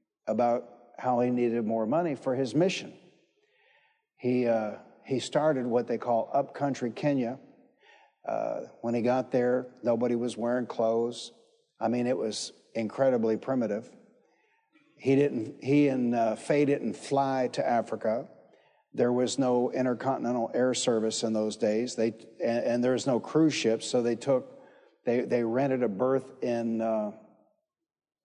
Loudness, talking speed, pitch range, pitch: -29 LUFS, 150 wpm, 115-135 Hz, 125 Hz